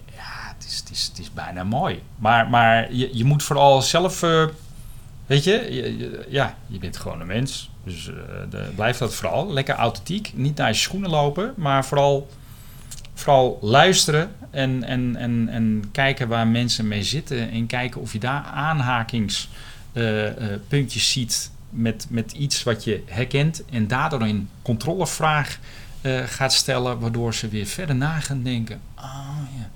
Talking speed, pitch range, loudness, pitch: 170 wpm, 115-140 Hz, -22 LUFS, 125 Hz